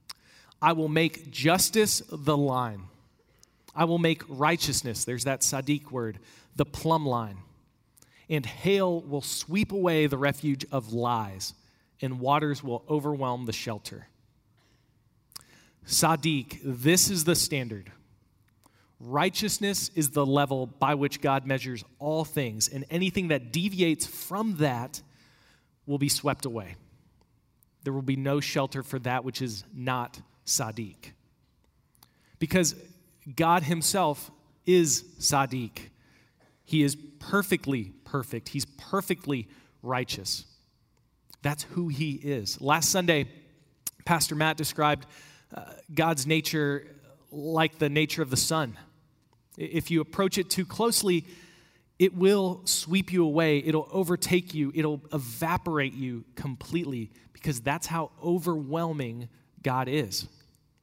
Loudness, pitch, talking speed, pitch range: -28 LUFS, 145 Hz, 120 wpm, 125-160 Hz